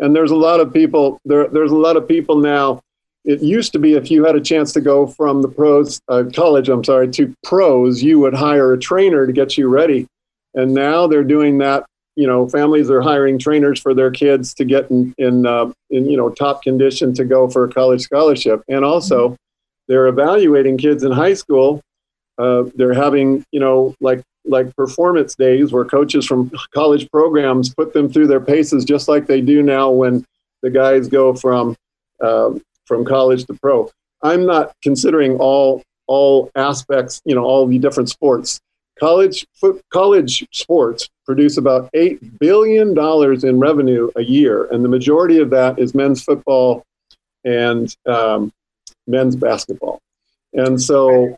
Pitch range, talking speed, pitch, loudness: 130-150 Hz, 180 wpm, 135 Hz, -14 LUFS